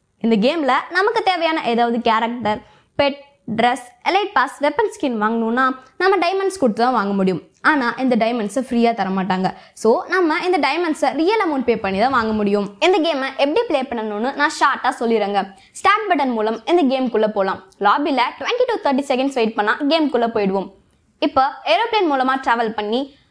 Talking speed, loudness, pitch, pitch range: 160 wpm, -18 LUFS, 260 Hz, 225-305 Hz